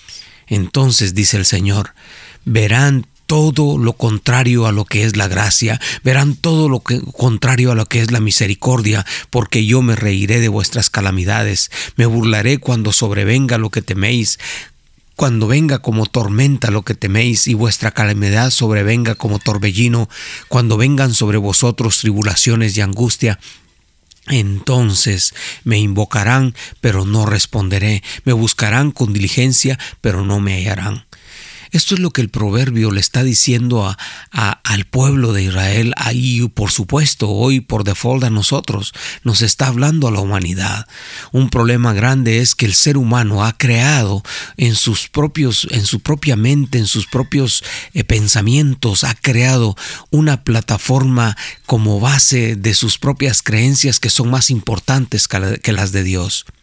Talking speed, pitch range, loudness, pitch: 150 wpm, 105-130 Hz, -14 LUFS, 115 Hz